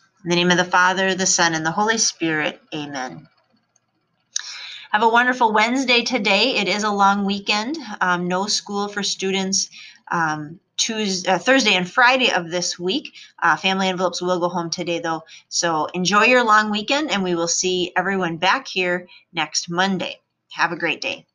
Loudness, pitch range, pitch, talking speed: -19 LUFS, 175-210 Hz, 190 Hz, 175 wpm